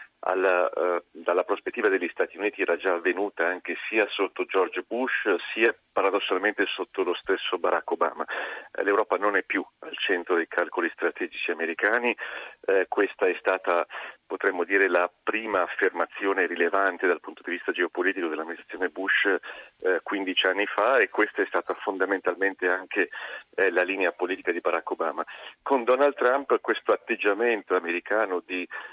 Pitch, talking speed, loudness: 130 Hz, 155 wpm, -26 LUFS